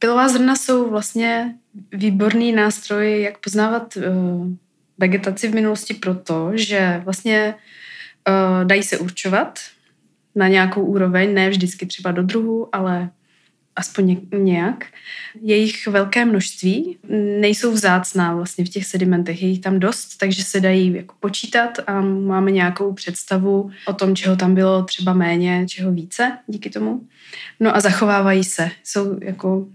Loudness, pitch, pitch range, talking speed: -18 LUFS, 195 Hz, 185-215 Hz, 135 wpm